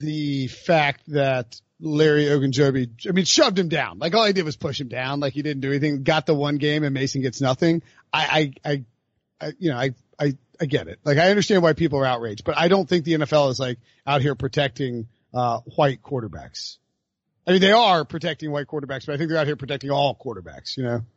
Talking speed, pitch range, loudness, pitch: 225 wpm, 135-160 Hz, -22 LUFS, 145 Hz